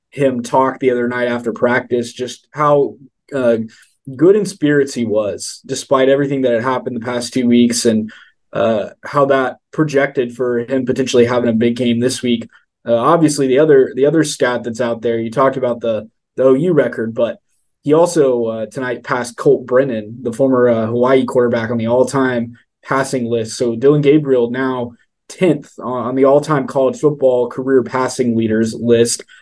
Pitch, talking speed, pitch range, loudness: 125 Hz, 180 wpm, 120-135 Hz, -15 LUFS